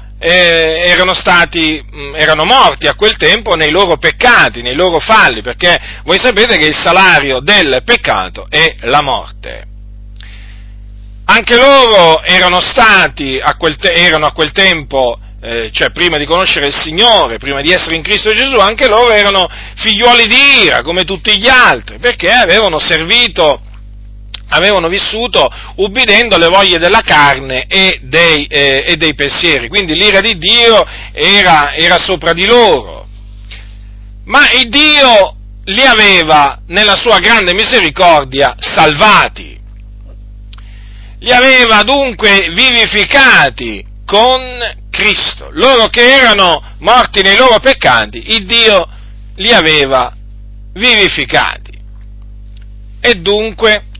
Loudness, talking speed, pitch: -7 LUFS, 125 wpm, 165 Hz